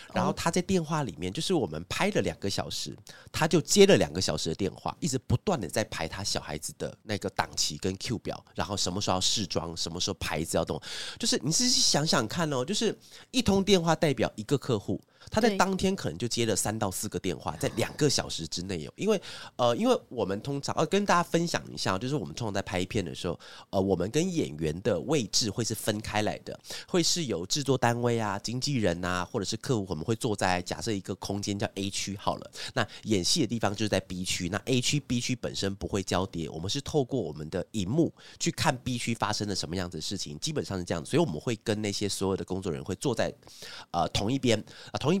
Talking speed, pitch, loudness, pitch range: 350 characters per minute, 110 Hz, -29 LUFS, 95-140 Hz